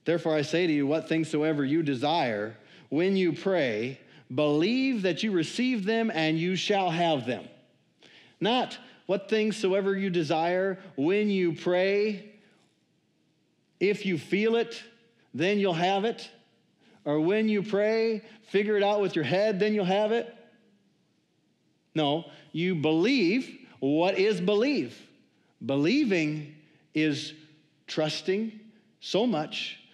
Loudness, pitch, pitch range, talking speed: -27 LUFS, 185 Hz, 155-210 Hz, 130 wpm